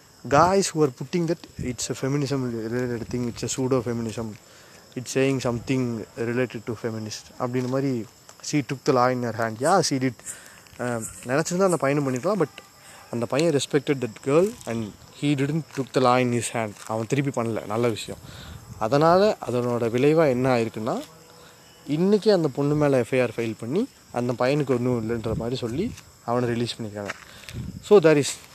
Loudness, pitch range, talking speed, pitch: -24 LUFS, 115-145 Hz, 170 wpm, 125 Hz